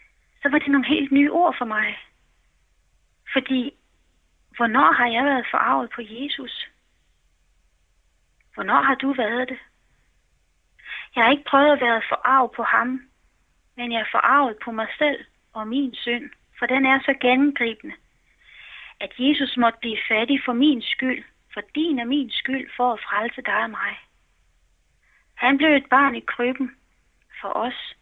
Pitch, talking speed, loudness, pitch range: 255 Hz, 155 wpm, -21 LUFS, 235-275 Hz